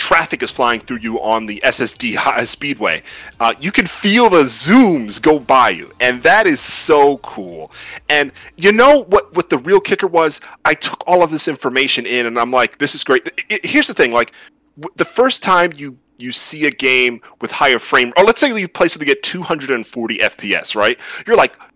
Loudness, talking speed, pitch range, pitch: -14 LUFS, 210 wpm, 125-195 Hz, 150 Hz